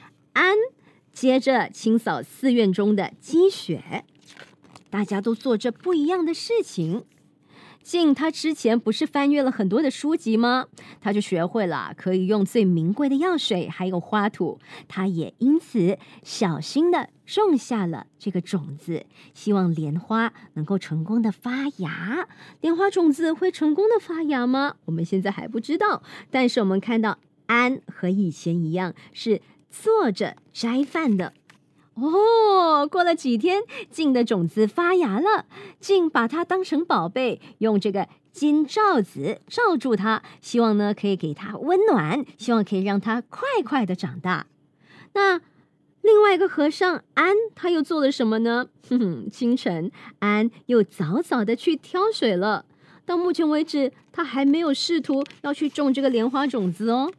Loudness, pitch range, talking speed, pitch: -23 LUFS, 205-325 Hz, 225 characters per minute, 250 Hz